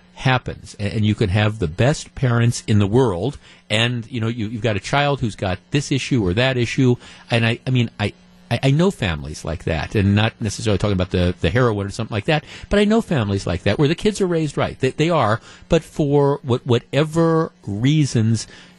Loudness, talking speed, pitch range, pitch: -20 LUFS, 220 wpm, 100-140 Hz, 115 Hz